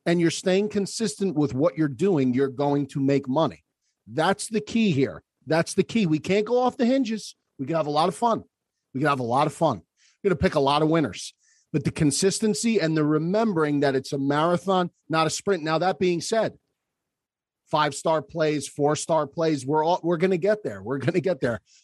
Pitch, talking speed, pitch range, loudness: 160 Hz, 230 wpm, 145-195 Hz, -24 LUFS